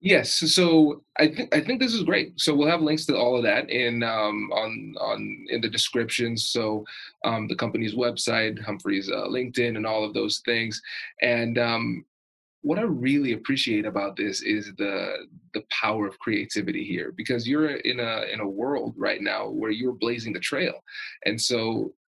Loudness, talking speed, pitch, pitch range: -25 LUFS, 185 wpm, 120 Hz, 110-150 Hz